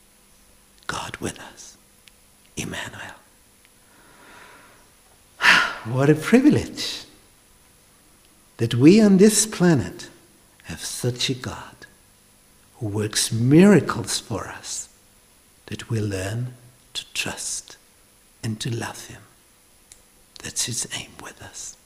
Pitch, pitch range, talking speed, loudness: 120 Hz, 105-155 Hz, 95 wpm, -21 LUFS